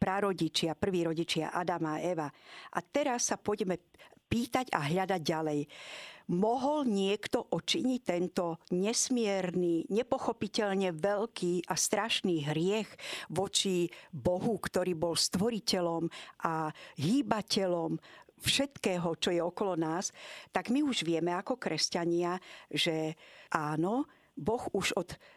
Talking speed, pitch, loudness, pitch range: 110 wpm, 180 Hz, -32 LUFS, 170-215 Hz